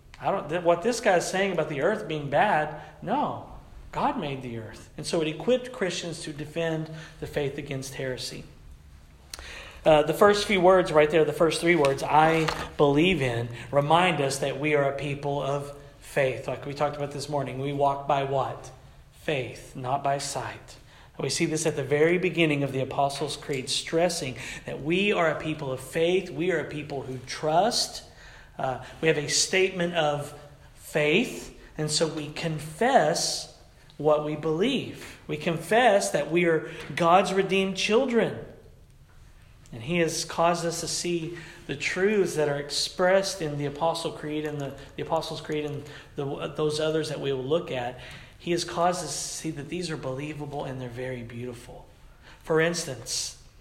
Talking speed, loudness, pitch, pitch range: 175 wpm, -26 LUFS, 150 Hz, 135-165 Hz